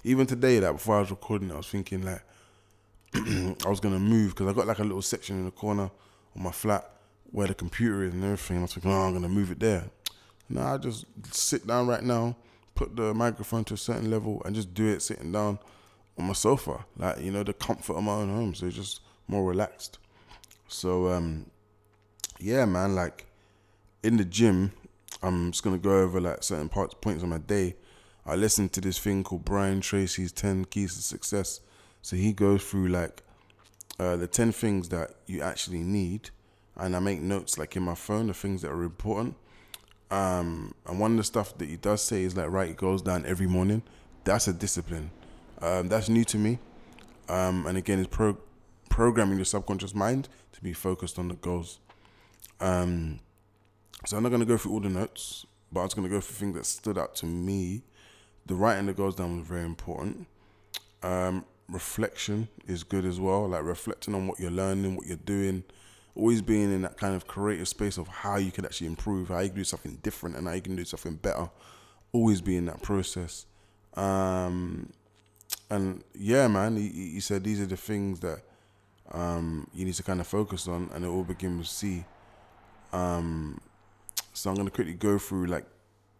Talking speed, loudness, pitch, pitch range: 205 wpm, -30 LUFS, 100 Hz, 90-105 Hz